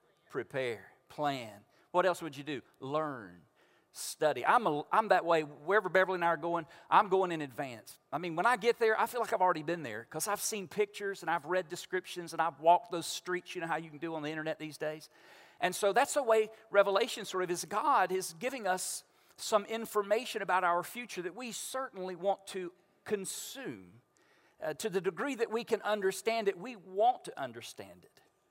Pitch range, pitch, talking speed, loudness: 165-215 Hz, 185 Hz, 210 wpm, -33 LUFS